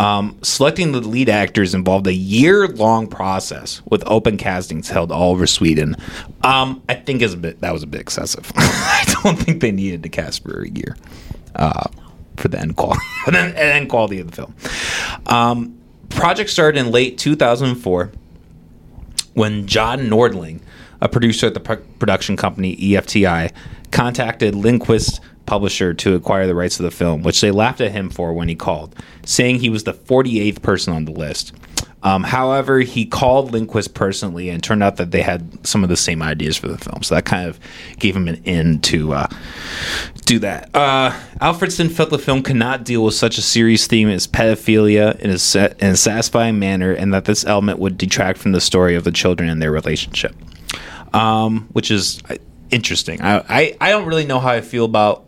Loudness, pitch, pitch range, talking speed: -16 LUFS, 105 Hz, 90-120 Hz, 190 wpm